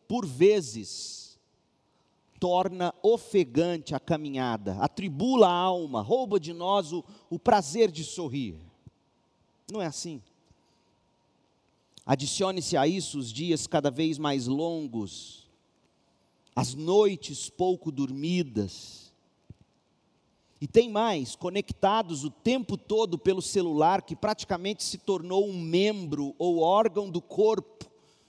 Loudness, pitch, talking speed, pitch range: -28 LUFS, 175 Hz, 110 wpm, 145-200 Hz